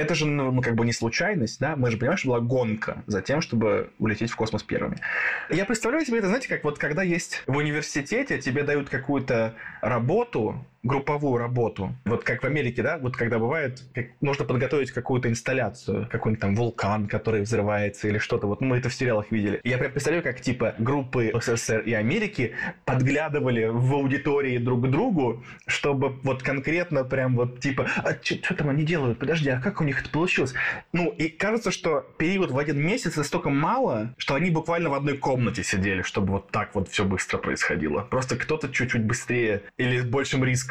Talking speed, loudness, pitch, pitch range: 190 wpm, -25 LUFS, 130 Hz, 115-145 Hz